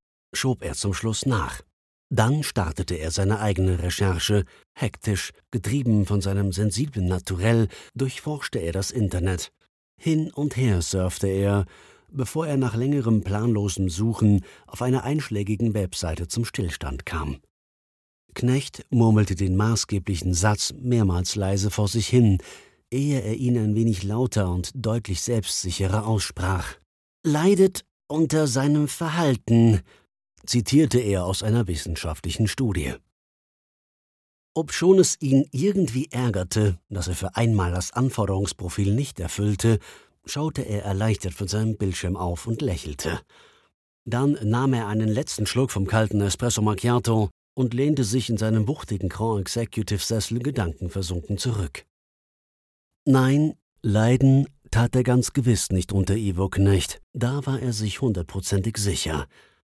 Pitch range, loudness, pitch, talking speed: 95-125 Hz, -24 LUFS, 110 Hz, 130 wpm